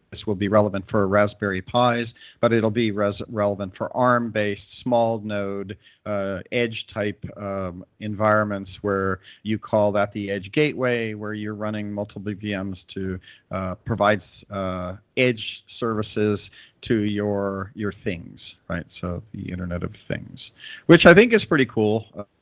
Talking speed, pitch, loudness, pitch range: 145 wpm, 105 Hz, -23 LUFS, 100-110 Hz